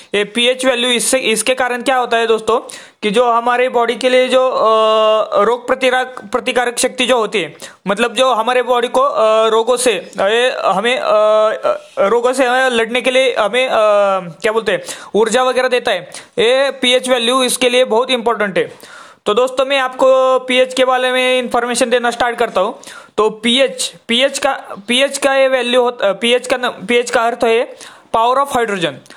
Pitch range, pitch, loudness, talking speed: 235-260 Hz, 250 Hz, -14 LUFS, 175 wpm